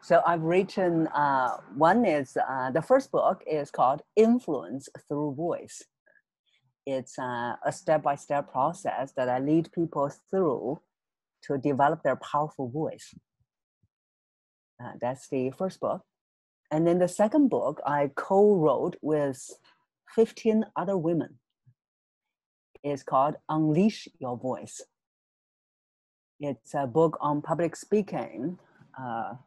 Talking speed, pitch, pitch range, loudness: 120 wpm, 150 Hz, 135-170 Hz, -27 LUFS